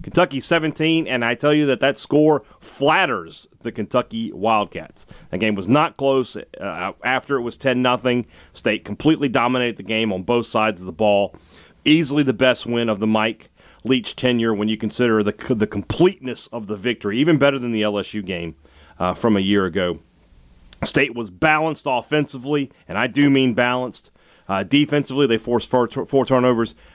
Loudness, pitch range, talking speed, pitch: -20 LUFS, 105-135 Hz, 180 wpm, 120 Hz